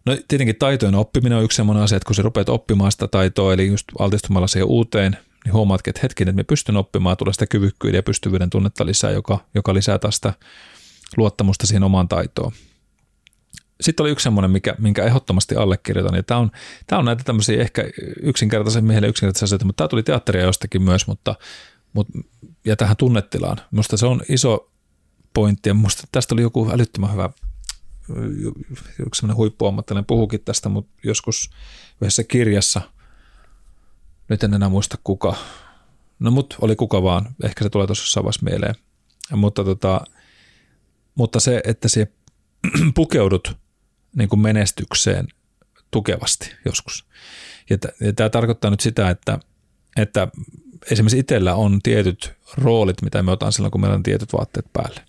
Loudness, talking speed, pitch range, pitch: -19 LUFS, 165 wpm, 95-115 Hz, 105 Hz